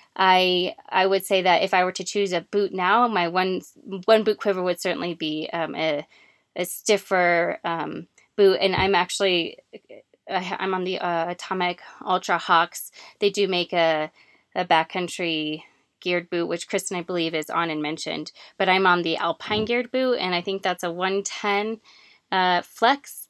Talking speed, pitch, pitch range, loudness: 175 wpm, 185 Hz, 175-195 Hz, -23 LUFS